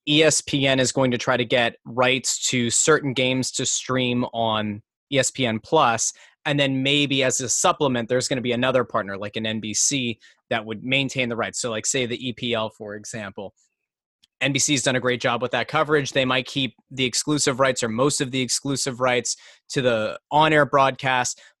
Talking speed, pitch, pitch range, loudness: 185 wpm, 130 Hz, 120-135 Hz, -22 LUFS